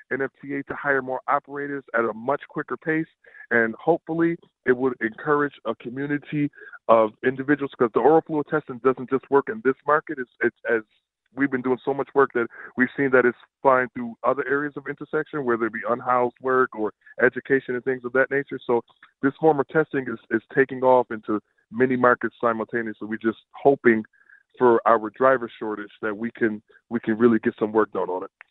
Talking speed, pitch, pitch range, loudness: 200 wpm, 130 Hz, 115-140 Hz, -23 LUFS